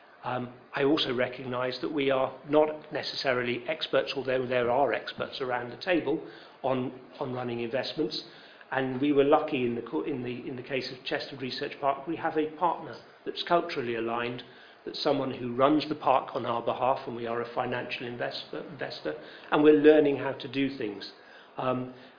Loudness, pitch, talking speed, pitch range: -29 LUFS, 130 Hz, 180 wpm, 125-150 Hz